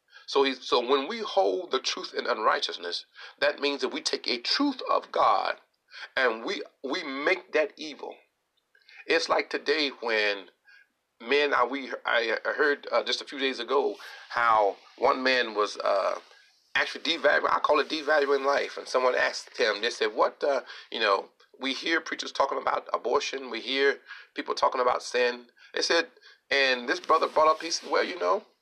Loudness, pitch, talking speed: -27 LUFS, 280 Hz, 180 wpm